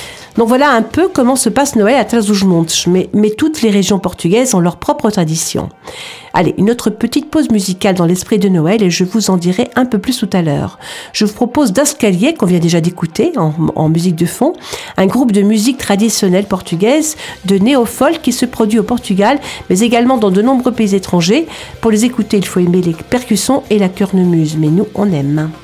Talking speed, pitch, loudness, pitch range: 210 wpm, 210 Hz, -12 LUFS, 185-250 Hz